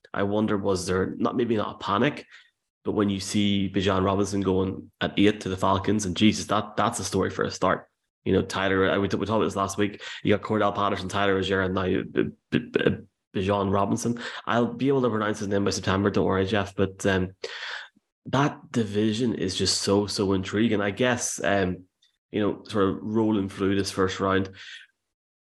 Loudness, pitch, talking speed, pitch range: -25 LUFS, 100 Hz, 205 wpm, 95-105 Hz